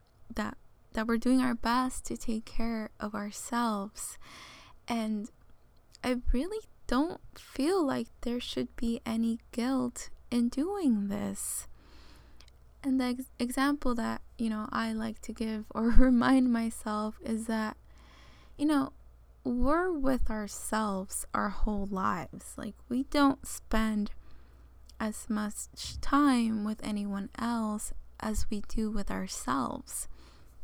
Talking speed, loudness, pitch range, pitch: 125 wpm, -32 LUFS, 205-250 Hz, 225 Hz